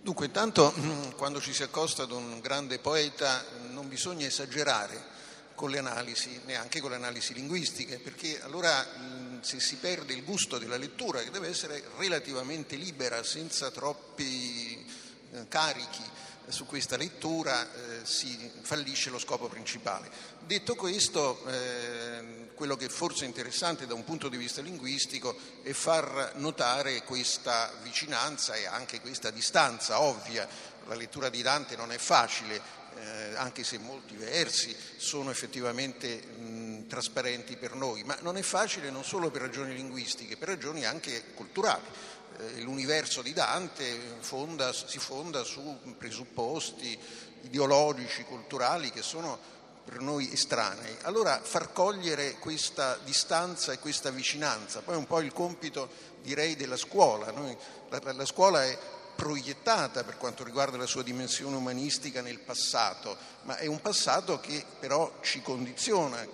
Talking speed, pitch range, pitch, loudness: 140 wpm, 125-150 Hz, 135 Hz, -32 LUFS